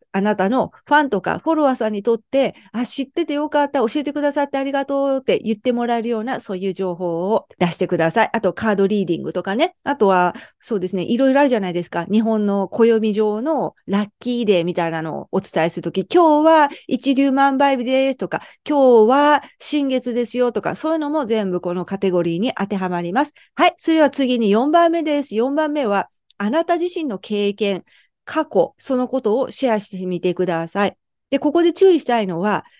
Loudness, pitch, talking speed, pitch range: -19 LUFS, 235 Hz, 410 characters per minute, 195-285 Hz